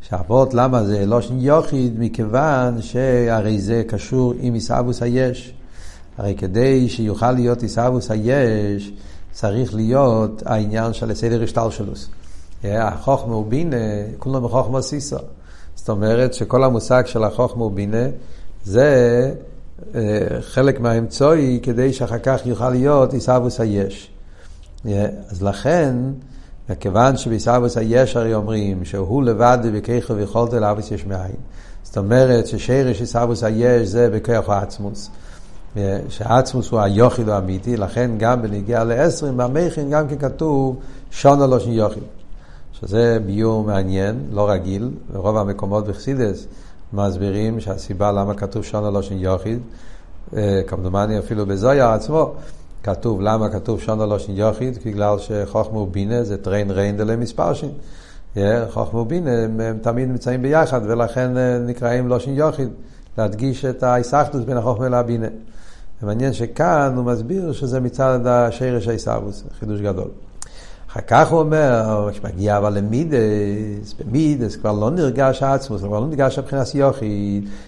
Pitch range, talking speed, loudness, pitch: 100-125 Hz, 130 wpm, -19 LUFS, 115 Hz